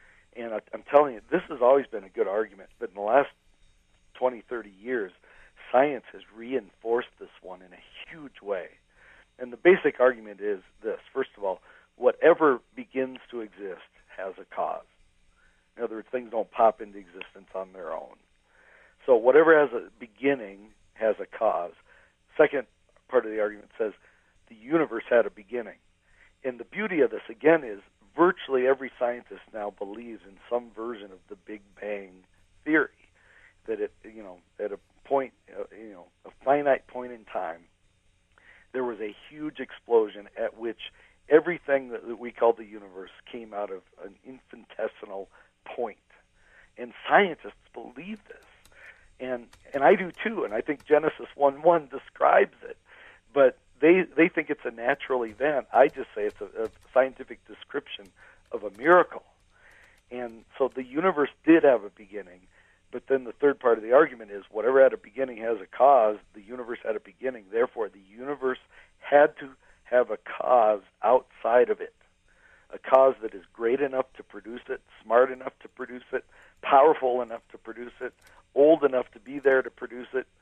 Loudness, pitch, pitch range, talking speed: -26 LUFS, 125 Hz, 105-150 Hz, 170 wpm